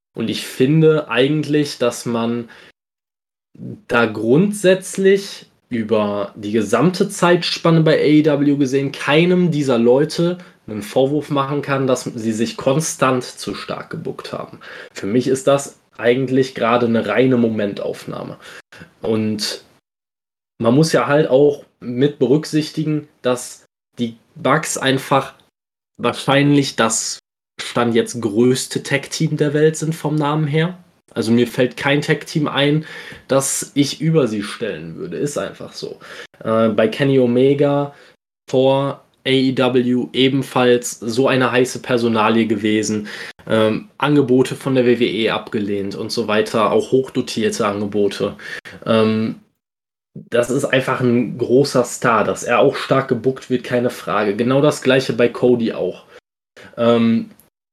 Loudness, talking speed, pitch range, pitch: -17 LUFS, 130 wpm, 115-145 Hz, 130 Hz